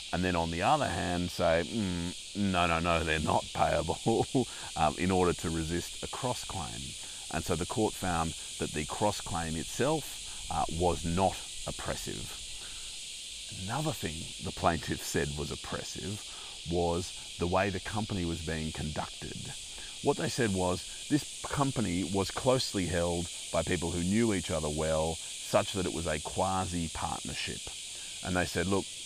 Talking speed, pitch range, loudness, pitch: 160 wpm, 80-95 Hz, -32 LUFS, 90 Hz